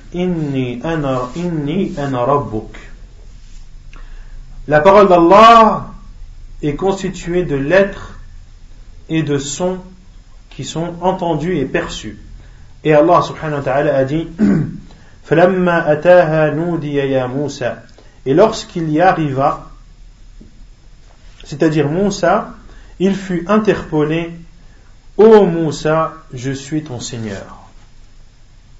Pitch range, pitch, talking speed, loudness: 120-175 Hz, 150 Hz, 90 wpm, -14 LUFS